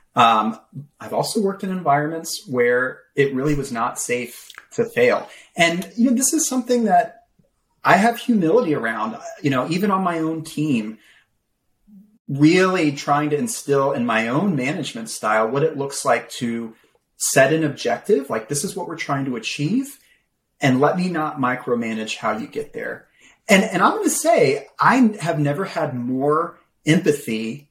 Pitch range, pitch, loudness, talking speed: 135-220 Hz, 160 Hz, -20 LUFS, 170 wpm